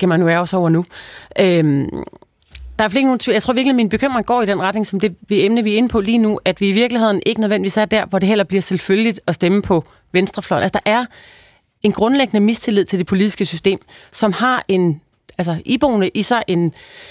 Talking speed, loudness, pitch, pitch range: 230 wpm, -16 LUFS, 205 Hz, 185-225 Hz